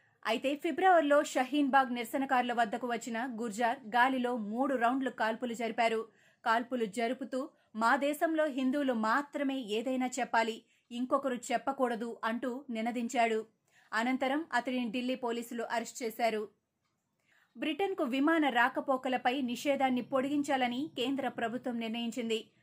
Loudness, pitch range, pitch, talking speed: -32 LUFS, 230-270 Hz, 250 Hz, 100 wpm